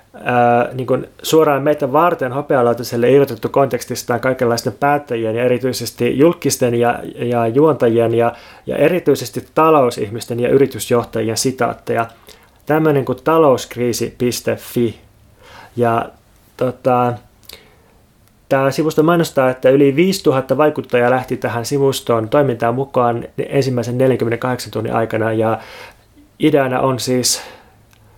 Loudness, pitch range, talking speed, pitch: -16 LUFS, 115-135 Hz, 100 wpm, 125 Hz